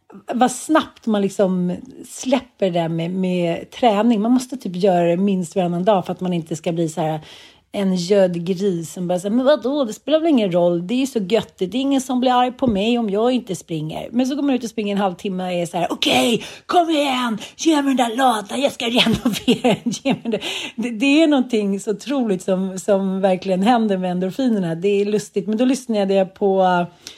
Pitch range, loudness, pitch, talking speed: 185-250 Hz, -19 LUFS, 210 Hz, 225 wpm